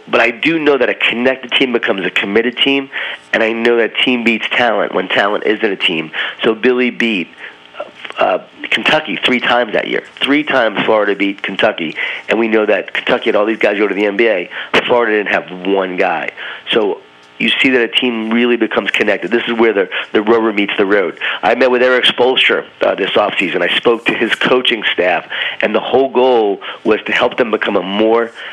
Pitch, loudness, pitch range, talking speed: 115 Hz, -13 LUFS, 105-125 Hz, 210 wpm